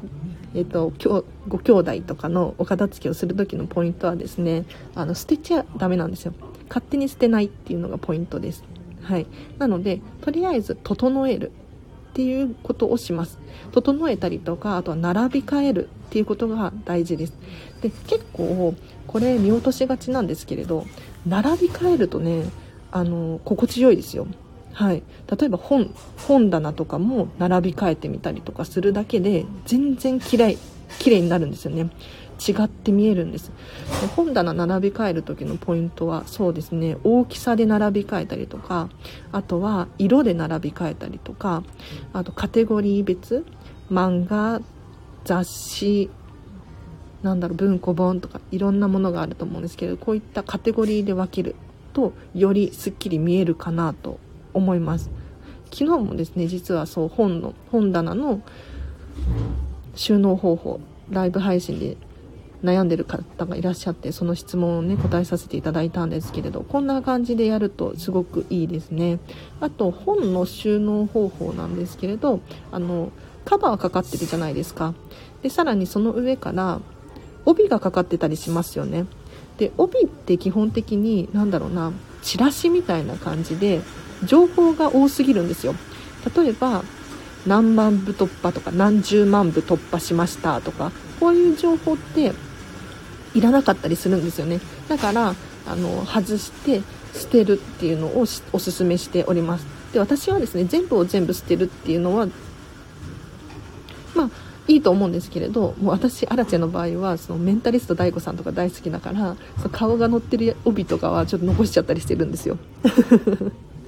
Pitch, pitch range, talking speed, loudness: 190 Hz, 170-230 Hz, 330 characters per minute, -22 LUFS